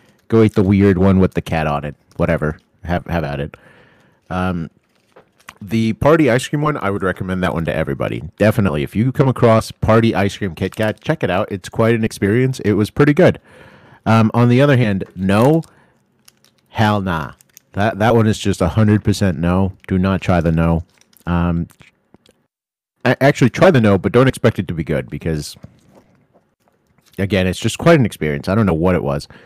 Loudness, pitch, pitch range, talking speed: -16 LUFS, 100 Hz, 90-115 Hz, 190 wpm